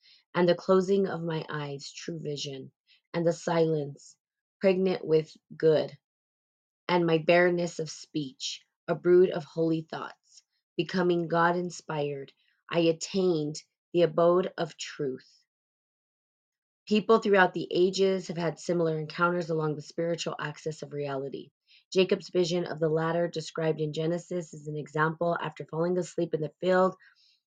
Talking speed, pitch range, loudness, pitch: 140 wpm, 155-180 Hz, -28 LUFS, 170 Hz